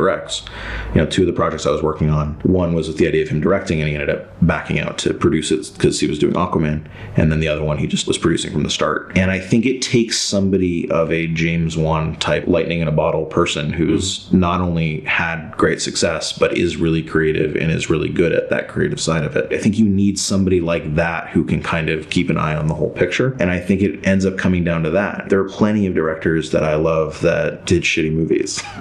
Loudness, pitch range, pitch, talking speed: -18 LUFS, 80-95 Hz, 85 Hz, 250 wpm